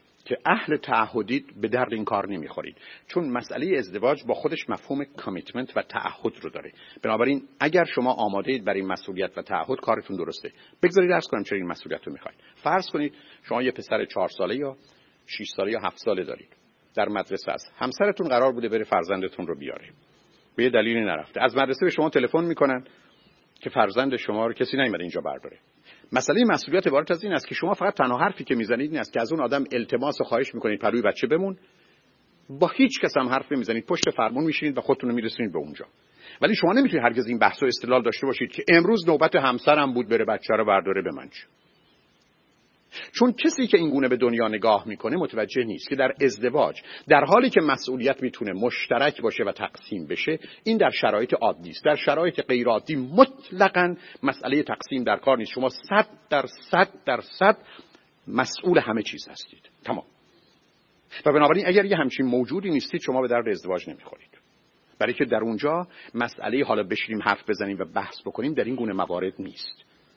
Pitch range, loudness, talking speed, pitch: 120-170 Hz, -24 LUFS, 190 wpm, 135 Hz